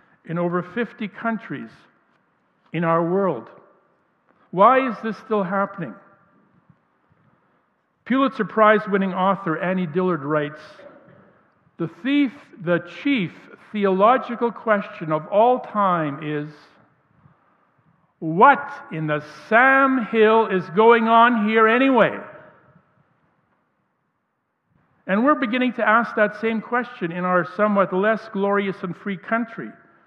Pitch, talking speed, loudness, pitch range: 200 Hz, 110 wpm, -20 LUFS, 170-225 Hz